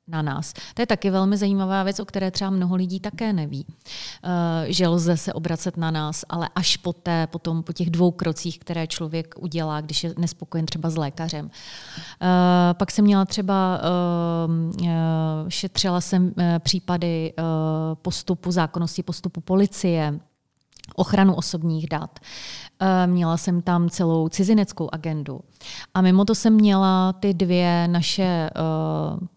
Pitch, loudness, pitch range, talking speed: 175 Hz, -22 LUFS, 165-185 Hz, 145 wpm